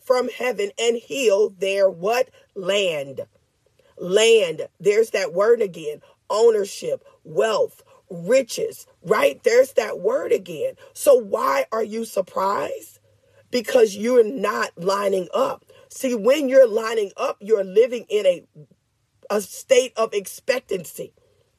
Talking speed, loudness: 120 wpm, -21 LUFS